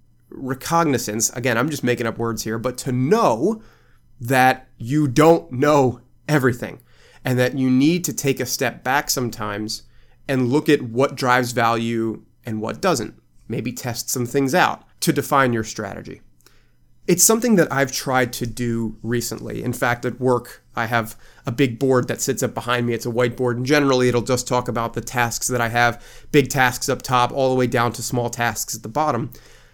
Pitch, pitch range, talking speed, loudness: 125 Hz, 120-135 Hz, 190 wpm, -20 LUFS